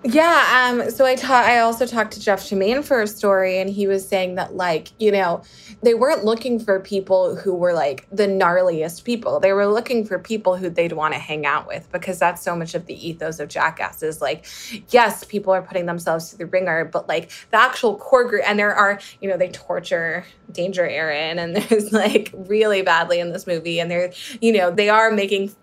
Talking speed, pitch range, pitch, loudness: 220 wpm, 175-220 Hz, 195 Hz, -19 LUFS